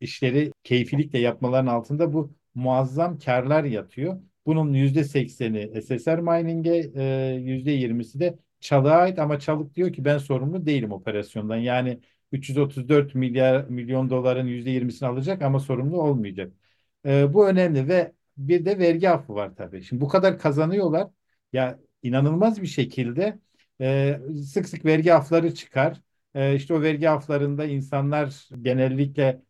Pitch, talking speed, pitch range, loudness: 140 Hz, 140 wpm, 130-160 Hz, -23 LUFS